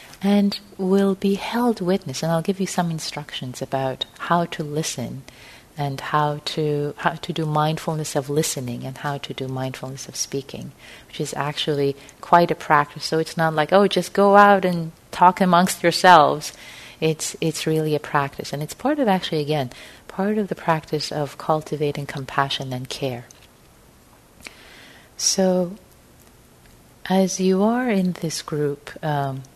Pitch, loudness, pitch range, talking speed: 155 Hz, -21 LUFS, 140-180 Hz, 155 wpm